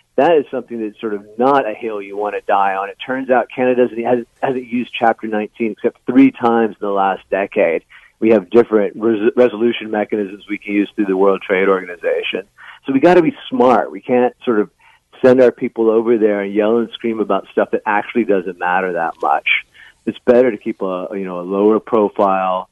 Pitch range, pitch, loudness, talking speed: 100-125 Hz, 110 Hz, -16 LUFS, 215 wpm